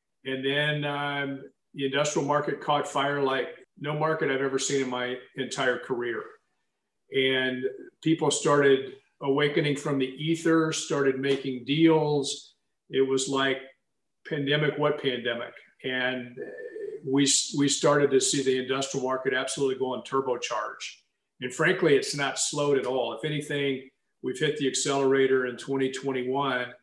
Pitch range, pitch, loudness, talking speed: 130-150 Hz, 135 Hz, -27 LUFS, 140 wpm